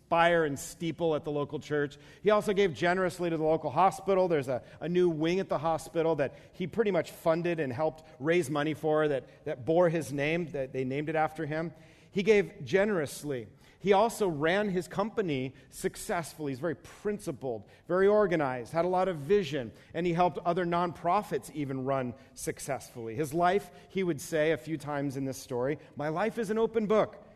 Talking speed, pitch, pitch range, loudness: 195 wpm, 165 Hz, 150-185 Hz, -30 LUFS